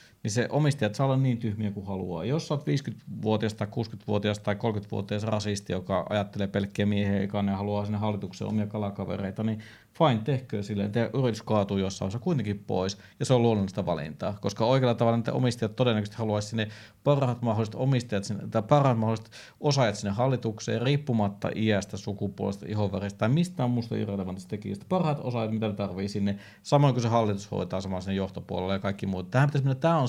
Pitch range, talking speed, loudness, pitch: 100-120 Hz, 180 wpm, -28 LUFS, 110 Hz